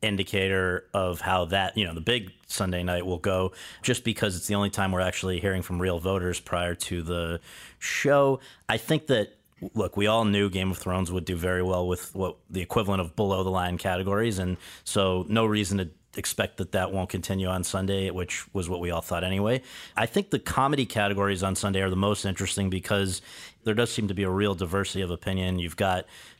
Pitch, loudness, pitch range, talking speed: 95 Hz, -27 LUFS, 90-105 Hz, 215 wpm